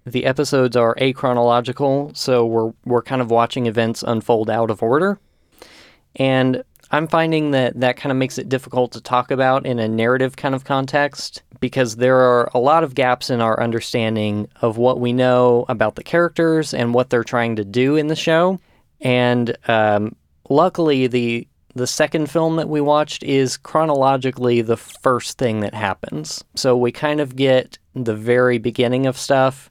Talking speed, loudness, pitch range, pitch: 175 wpm, -18 LUFS, 120-135 Hz, 125 Hz